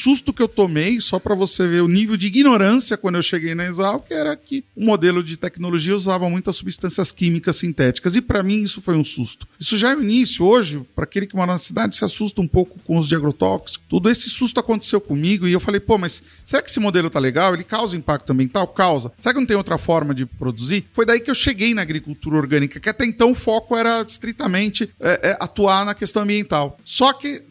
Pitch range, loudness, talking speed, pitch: 170-225 Hz, -18 LUFS, 235 wpm, 195 Hz